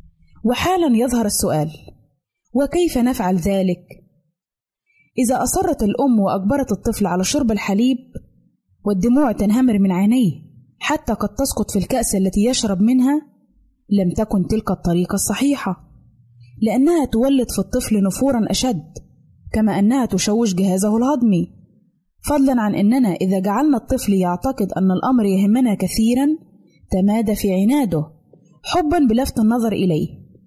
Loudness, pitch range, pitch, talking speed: -18 LUFS, 190-250 Hz, 215 Hz, 120 wpm